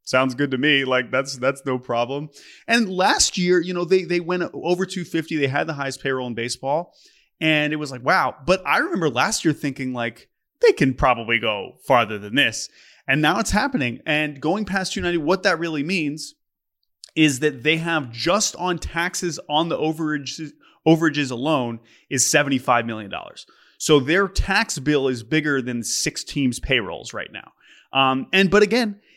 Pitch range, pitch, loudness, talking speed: 130-175 Hz, 150 Hz, -21 LUFS, 195 wpm